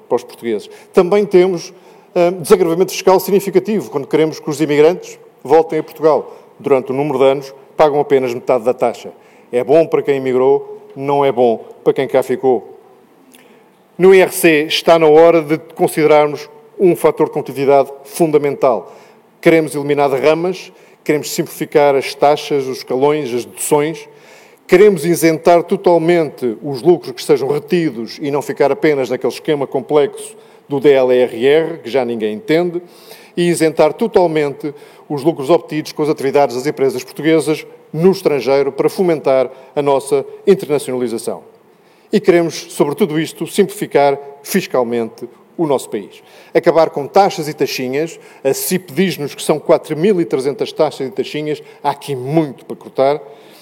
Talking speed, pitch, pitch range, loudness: 150 wpm, 155 Hz, 140-185 Hz, -15 LUFS